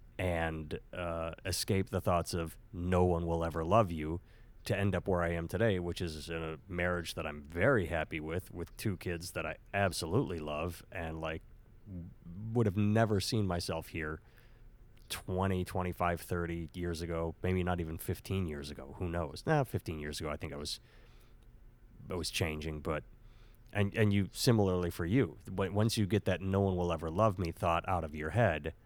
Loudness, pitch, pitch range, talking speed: -35 LUFS, 90 Hz, 85-105 Hz, 190 wpm